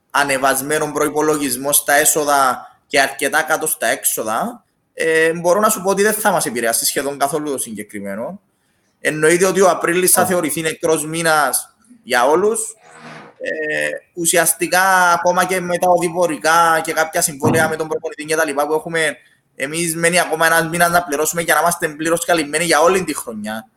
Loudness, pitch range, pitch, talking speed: -16 LUFS, 150-175 Hz, 160 Hz, 170 wpm